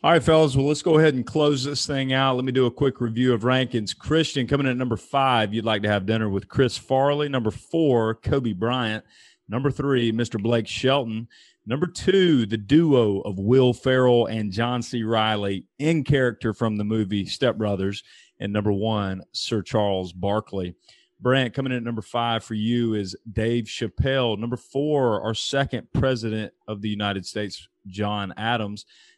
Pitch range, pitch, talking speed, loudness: 105-135 Hz, 115 Hz, 185 wpm, -23 LUFS